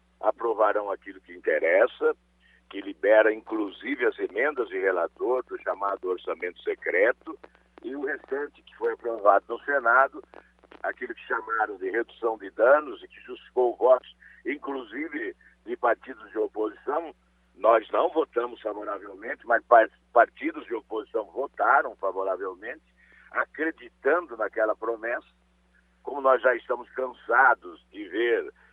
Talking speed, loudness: 125 wpm, -26 LUFS